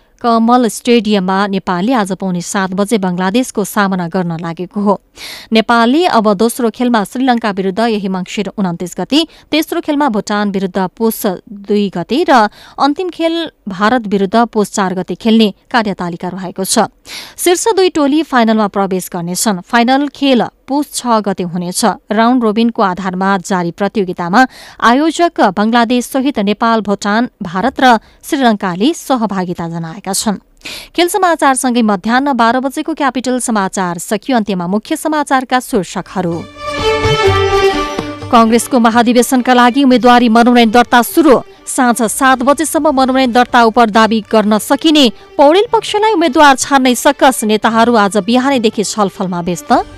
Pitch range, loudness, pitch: 200-265 Hz, -12 LUFS, 230 Hz